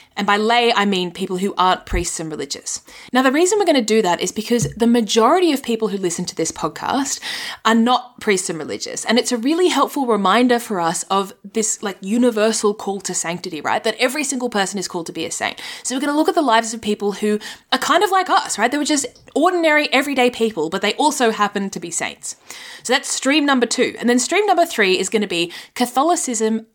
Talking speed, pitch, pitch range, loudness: 240 wpm, 225 Hz, 195-260 Hz, -18 LUFS